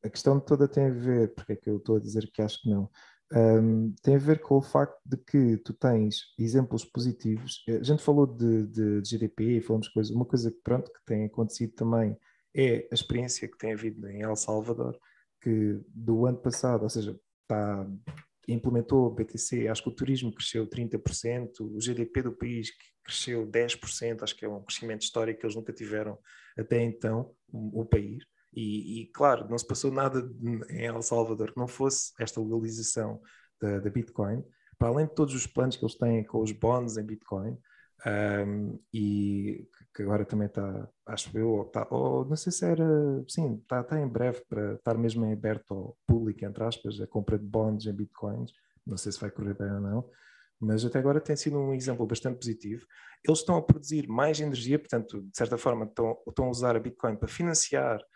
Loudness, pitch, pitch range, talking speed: -30 LUFS, 115 Hz, 110-125 Hz, 200 wpm